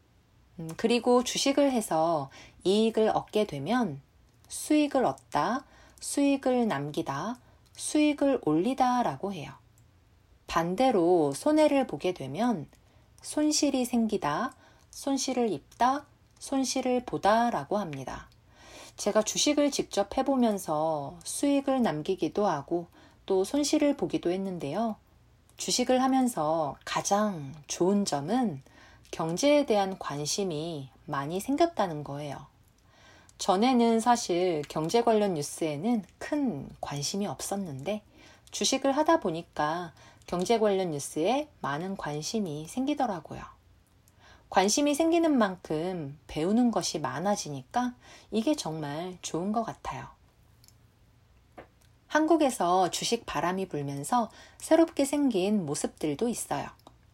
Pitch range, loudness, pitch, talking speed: 155-250 Hz, -28 LUFS, 195 Hz, 235 characters per minute